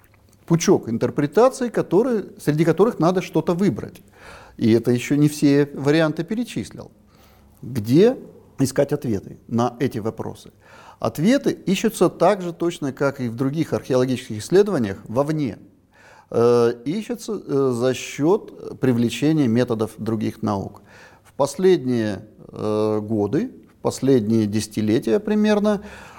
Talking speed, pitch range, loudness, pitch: 110 wpm, 115-170 Hz, -21 LUFS, 135 Hz